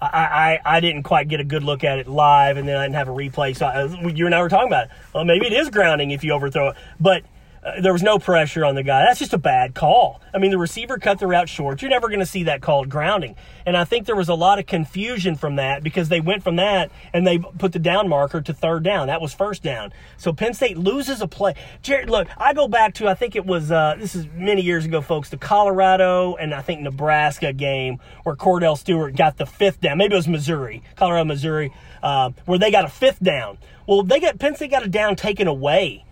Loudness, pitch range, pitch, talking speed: -19 LUFS, 150-195 Hz, 175 Hz, 260 wpm